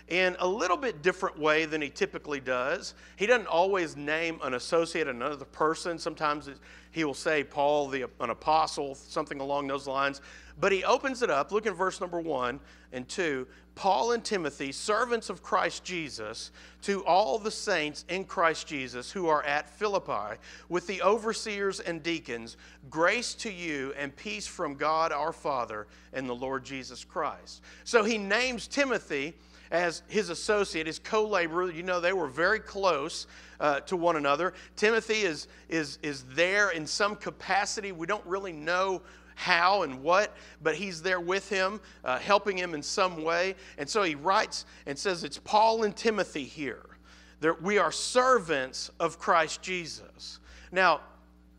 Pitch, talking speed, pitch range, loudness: 165 Hz, 165 wpm, 140-195 Hz, -29 LUFS